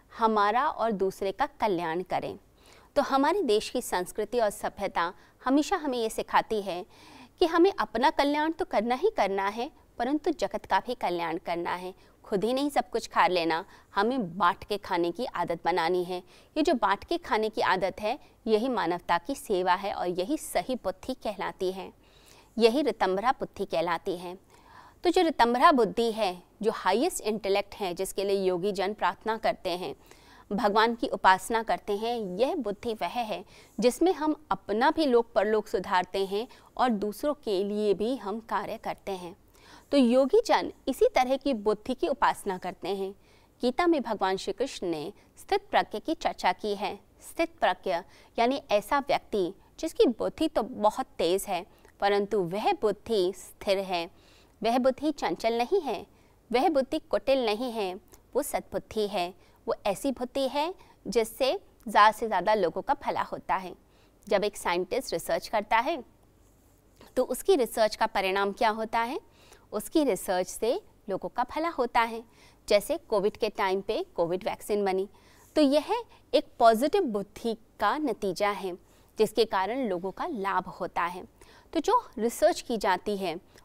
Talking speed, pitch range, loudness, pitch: 165 wpm, 195-275 Hz, -28 LUFS, 220 Hz